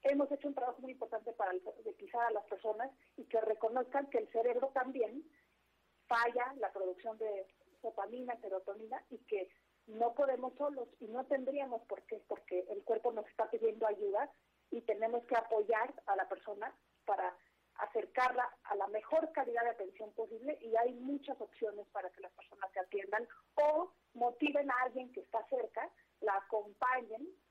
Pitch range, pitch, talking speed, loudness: 215-260 Hz, 235 Hz, 165 wpm, -39 LUFS